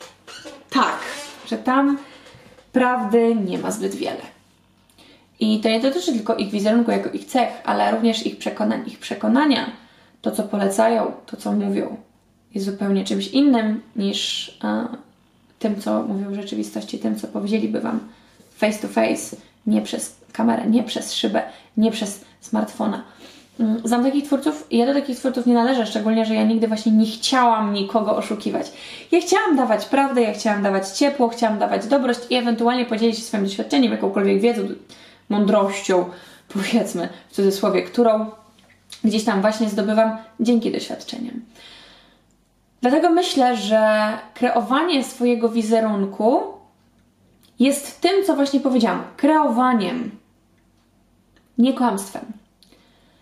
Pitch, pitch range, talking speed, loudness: 230 Hz, 215-250 Hz, 135 wpm, -20 LUFS